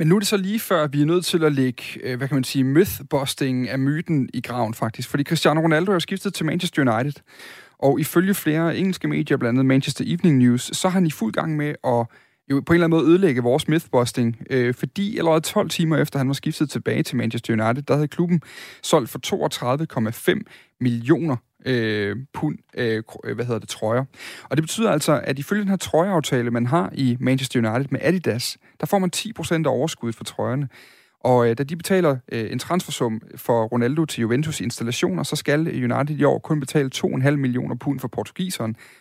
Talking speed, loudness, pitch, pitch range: 205 wpm, -22 LUFS, 140 Hz, 125-165 Hz